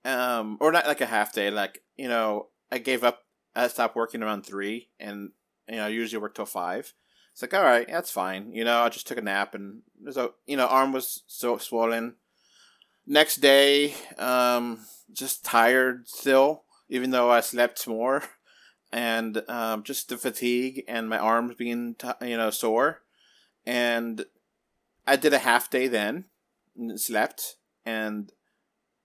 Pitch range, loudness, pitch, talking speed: 115-125 Hz, -25 LUFS, 120 Hz, 165 wpm